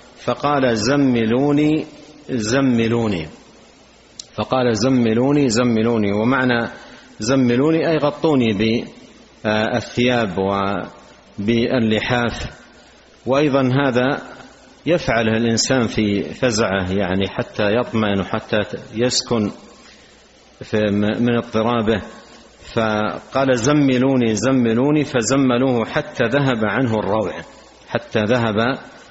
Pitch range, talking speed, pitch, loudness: 110-130 Hz, 75 wpm, 120 Hz, -18 LUFS